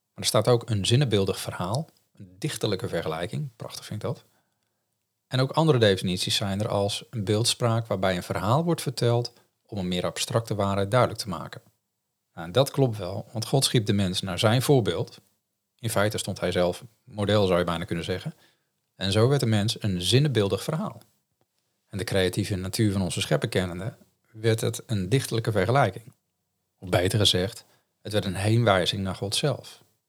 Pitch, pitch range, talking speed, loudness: 110 Hz, 95-120 Hz, 180 wpm, -25 LUFS